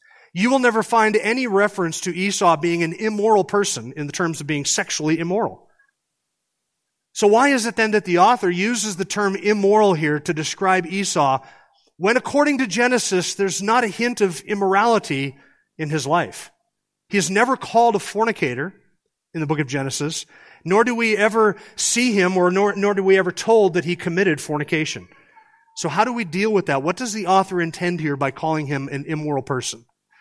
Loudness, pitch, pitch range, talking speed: -19 LUFS, 195 Hz, 160-220 Hz, 190 wpm